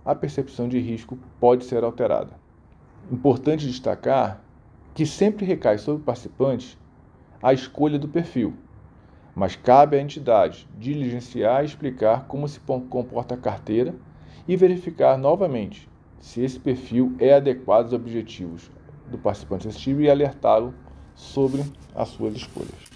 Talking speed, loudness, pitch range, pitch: 130 wpm, -22 LUFS, 120-145 Hz, 130 Hz